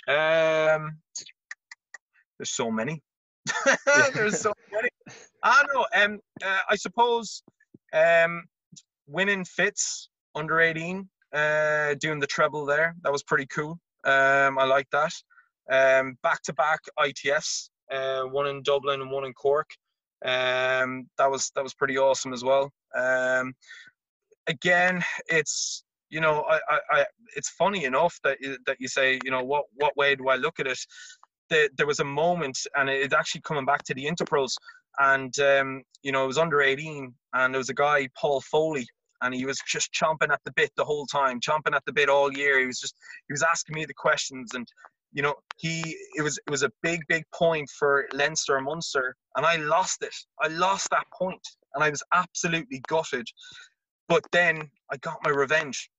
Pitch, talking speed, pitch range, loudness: 150 Hz, 180 wpm, 135-185 Hz, -25 LUFS